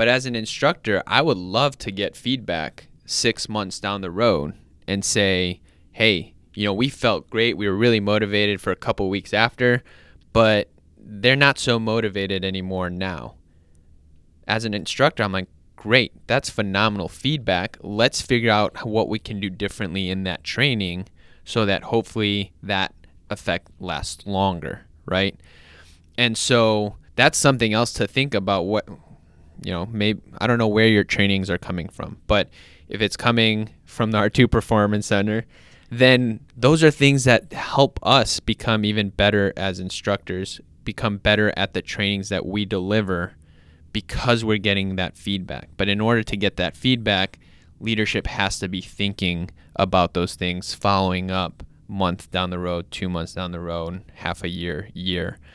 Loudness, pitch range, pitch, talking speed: -21 LUFS, 90-110 Hz, 100 Hz, 165 wpm